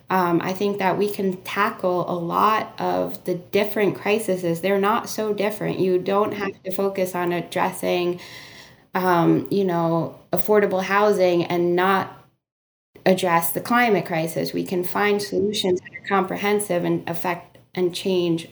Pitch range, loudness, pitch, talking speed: 170-200 Hz, -22 LUFS, 185 Hz, 150 wpm